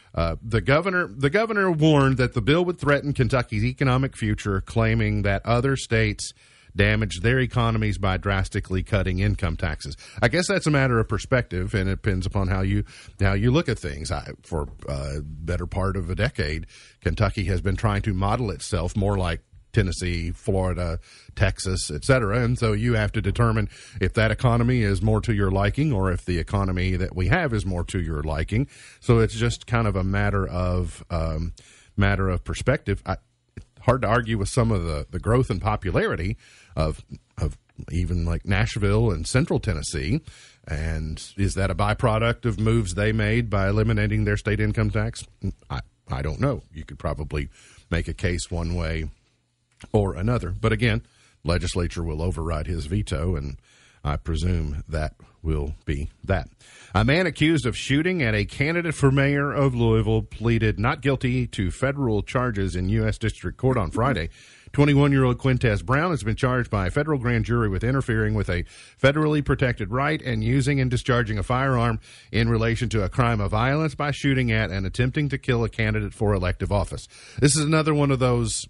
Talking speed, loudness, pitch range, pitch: 185 wpm, -24 LUFS, 90-120 Hz, 105 Hz